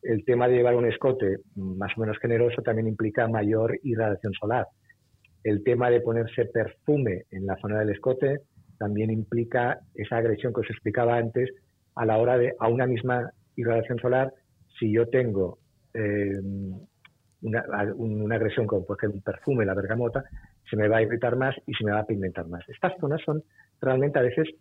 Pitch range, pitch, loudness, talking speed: 105-125 Hz, 115 Hz, -26 LUFS, 185 wpm